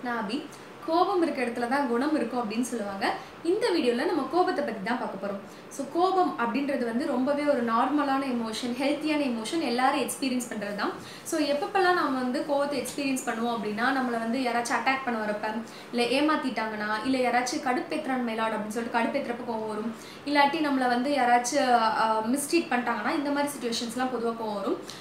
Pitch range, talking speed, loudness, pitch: 235-285 Hz, 160 wpm, -27 LUFS, 255 Hz